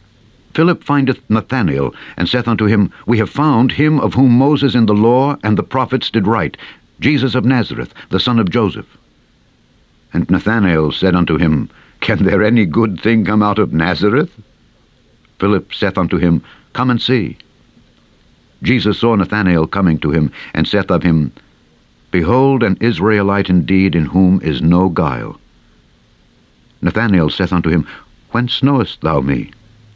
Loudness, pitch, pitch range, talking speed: -14 LUFS, 105 Hz, 90-125 Hz, 155 wpm